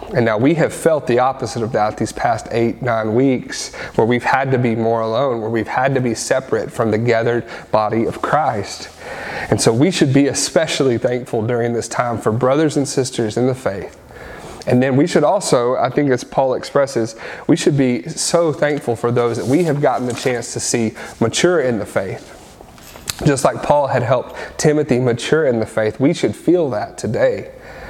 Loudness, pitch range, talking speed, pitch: -17 LUFS, 115-140 Hz, 200 wpm, 120 Hz